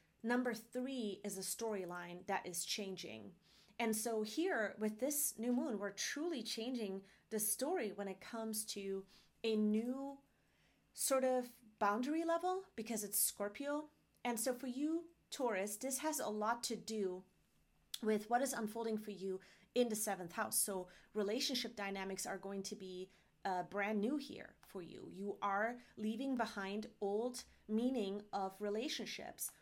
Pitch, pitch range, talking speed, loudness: 215 Hz, 200-245 Hz, 150 wpm, -41 LUFS